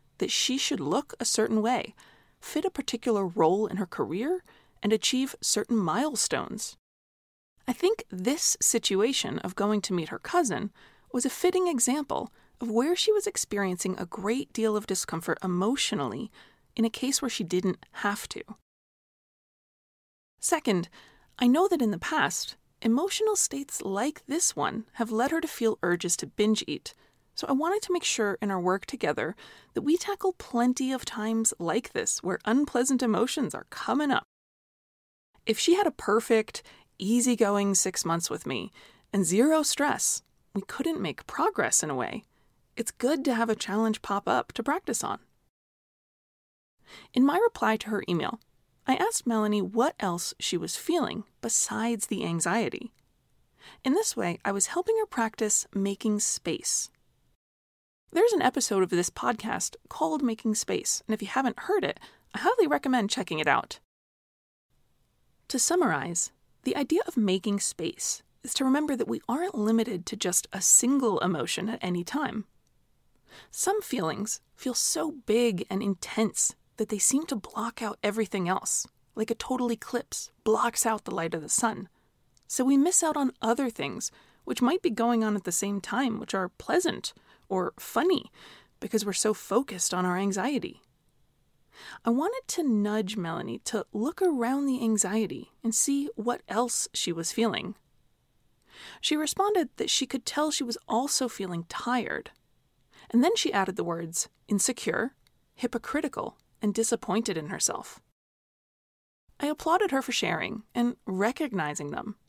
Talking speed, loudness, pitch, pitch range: 160 wpm, -28 LUFS, 230 Hz, 205-280 Hz